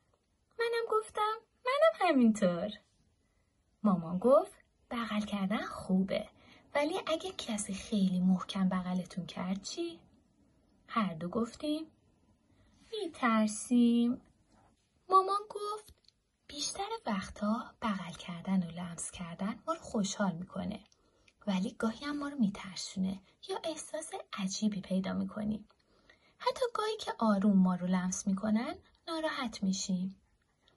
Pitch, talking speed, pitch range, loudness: 215 Hz, 105 wpm, 190-310 Hz, -34 LUFS